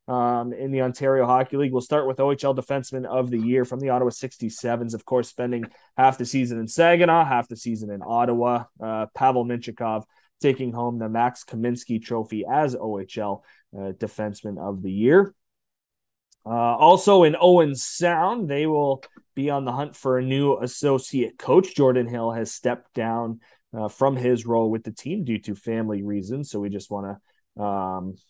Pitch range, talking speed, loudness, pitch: 110-130 Hz, 180 wpm, -23 LUFS, 120 Hz